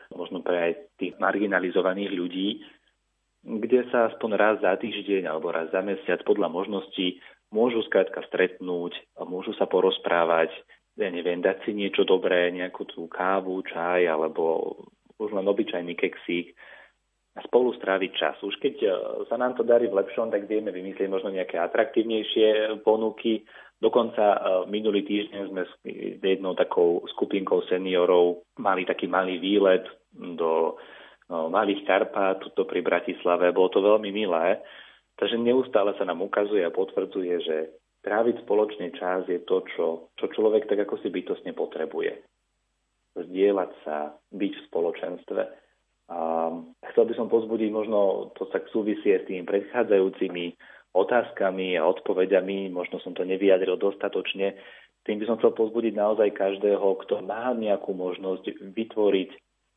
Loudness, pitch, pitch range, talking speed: -26 LUFS, 100 Hz, 90-120 Hz, 145 wpm